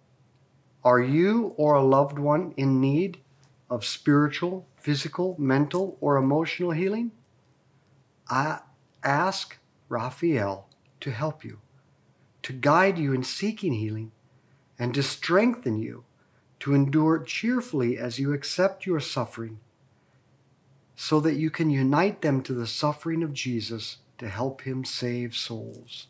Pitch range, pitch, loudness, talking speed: 125-160 Hz, 140 Hz, -26 LUFS, 125 wpm